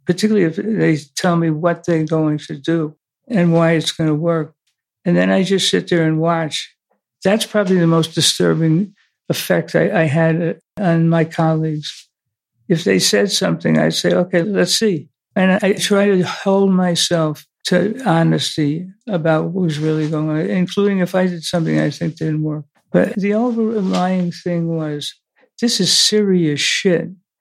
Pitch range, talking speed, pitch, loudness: 155-185 Hz, 170 wpm, 170 Hz, -17 LUFS